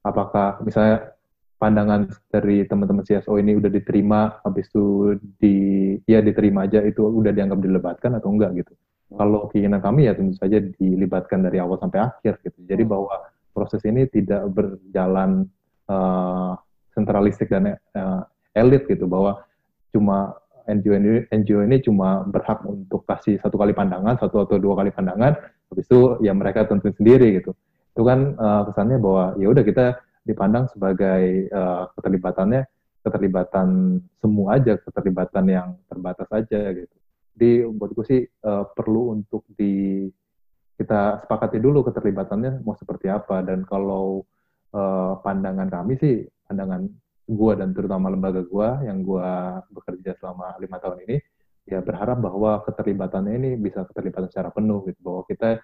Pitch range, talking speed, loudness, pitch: 95-110 Hz, 145 wpm, -21 LUFS, 100 Hz